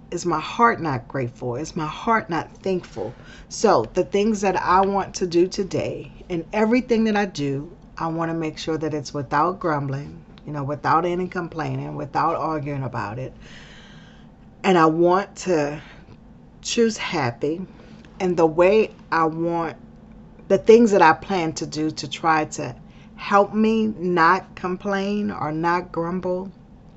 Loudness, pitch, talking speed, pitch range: -22 LUFS, 170 Hz, 155 wpm, 155-195 Hz